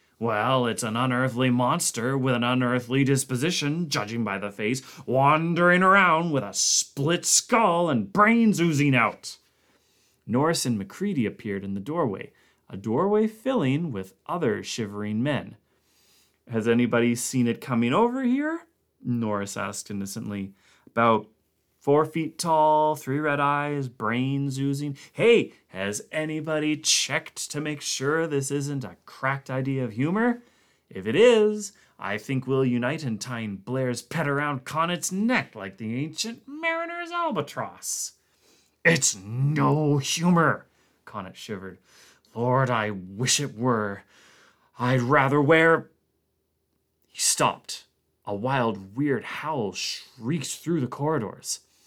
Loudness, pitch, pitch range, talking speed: -24 LUFS, 135 Hz, 115-160 Hz, 130 wpm